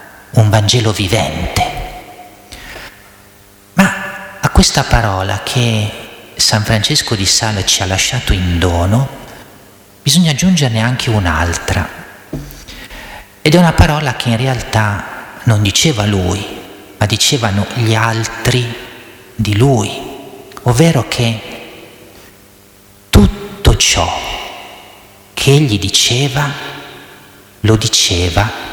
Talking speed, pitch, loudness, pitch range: 95 wpm, 110 Hz, -13 LUFS, 100-125 Hz